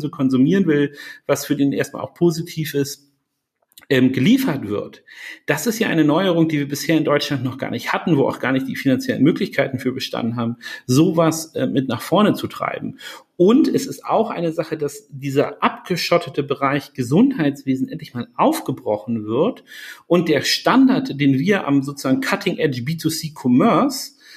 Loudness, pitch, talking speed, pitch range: -19 LUFS, 145 Hz, 170 wpm, 135-175 Hz